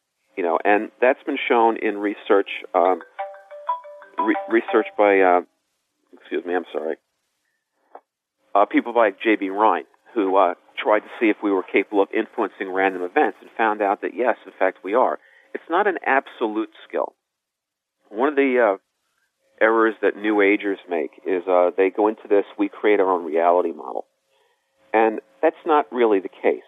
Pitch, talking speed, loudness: 110 Hz, 170 wpm, -21 LUFS